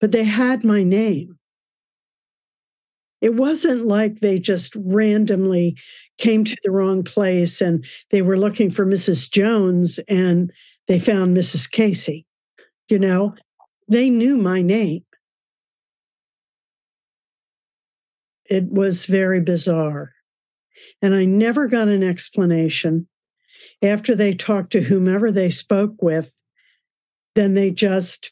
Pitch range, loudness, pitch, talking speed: 180-215 Hz, -18 LUFS, 195 Hz, 115 wpm